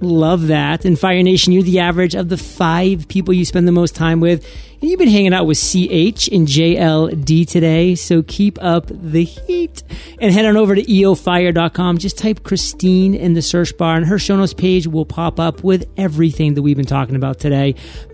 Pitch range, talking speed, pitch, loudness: 165-185 Hz, 205 wpm, 175 Hz, -14 LUFS